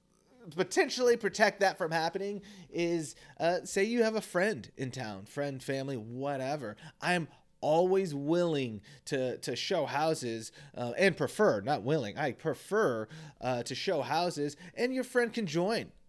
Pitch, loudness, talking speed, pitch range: 170 Hz, -32 LUFS, 150 wpm, 140-195 Hz